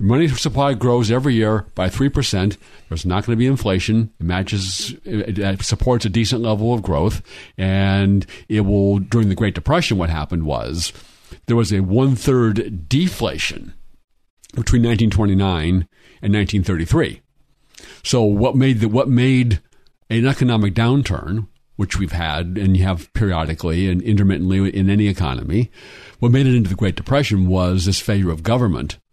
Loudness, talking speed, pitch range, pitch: -18 LUFS, 155 wpm, 95-120 Hz, 105 Hz